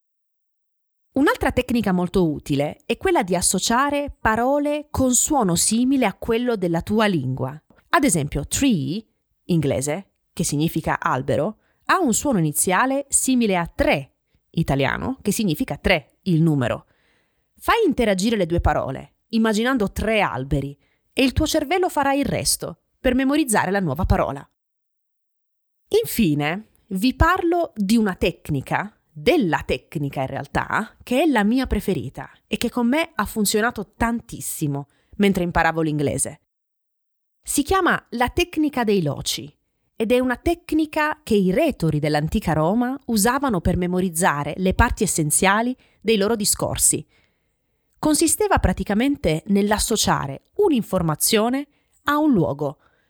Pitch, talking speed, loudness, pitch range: 210 Hz, 130 wpm, -21 LUFS, 160-255 Hz